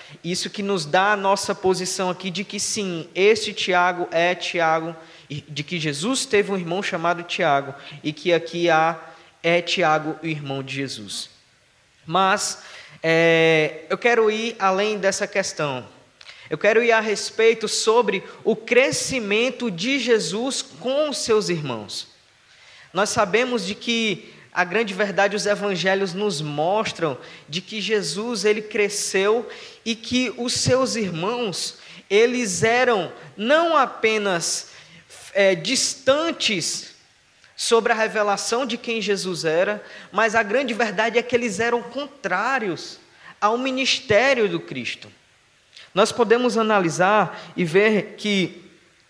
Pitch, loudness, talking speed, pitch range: 200 Hz, -21 LUFS, 130 wpm, 170-225 Hz